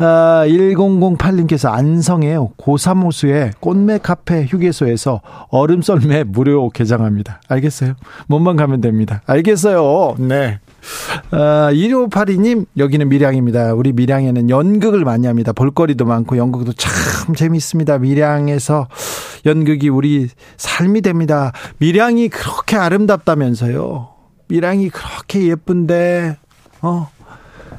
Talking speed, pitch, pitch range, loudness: 270 characters per minute, 150 Hz, 130-175 Hz, -14 LUFS